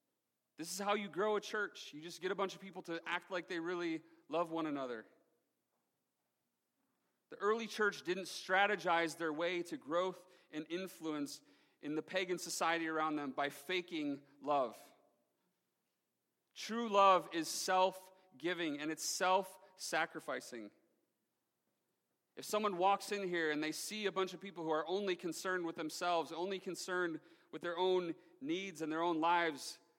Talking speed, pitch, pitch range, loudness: 160 wpm, 180 Hz, 160-195 Hz, -38 LUFS